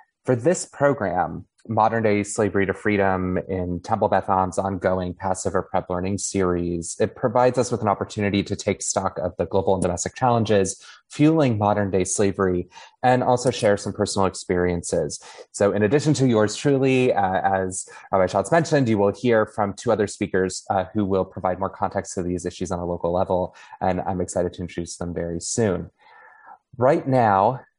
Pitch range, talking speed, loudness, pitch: 95-110 Hz, 180 wpm, -22 LUFS, 100 Hz